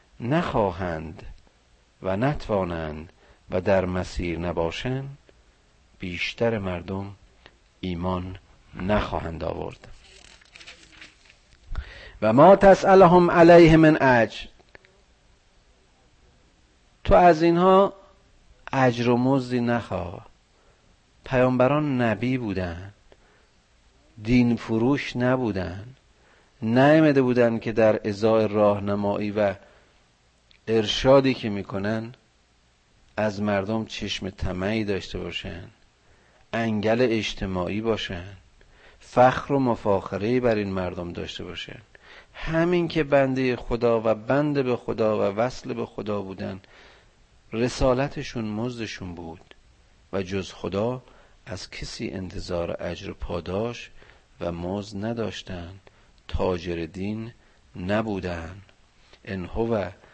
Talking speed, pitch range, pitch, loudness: 90 wpm, 90-120 Hz, 100 Hz, -23 LUFS